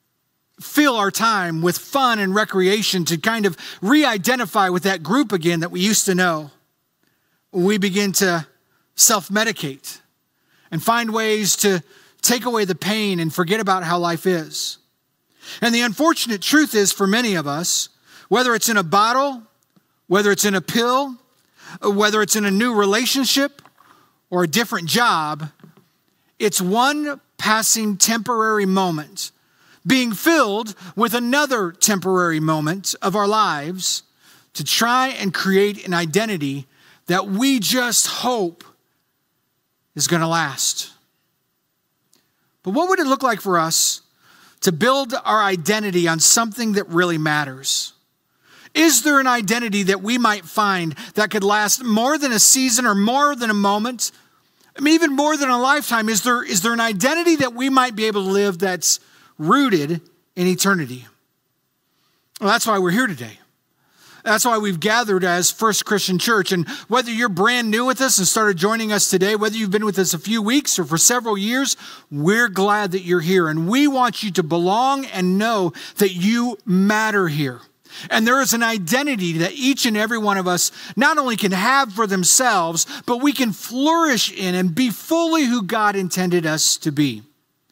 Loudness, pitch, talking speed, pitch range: -18 LUFS, 210 Hz, 170 wpm, 185-240 Hz